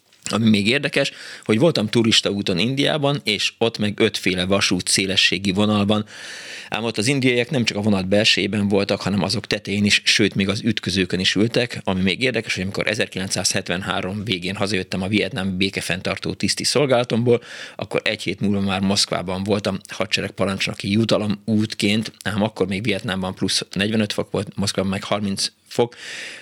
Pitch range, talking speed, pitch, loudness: 95-110 Hz, 160 wpm, 100 Hz, -20 LUFS